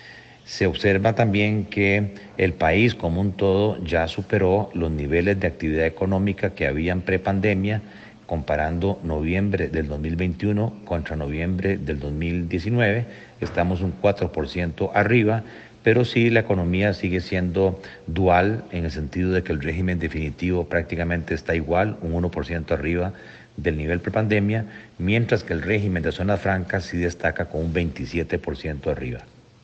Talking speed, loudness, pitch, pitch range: 140 wpm, -23 LUFS, 90 Hz, 85-105 Hz